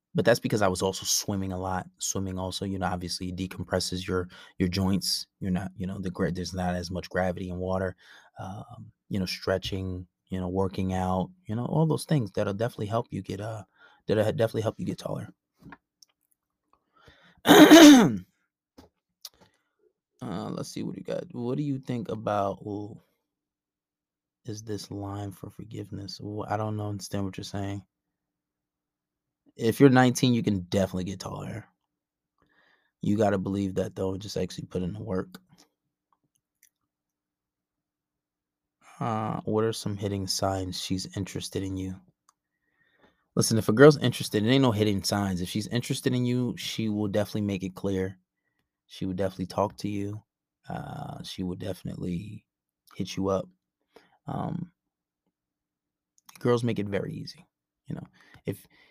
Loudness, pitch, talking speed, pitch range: -26 LUFS, 100 Hz, 155 wpm, 90-110 Hz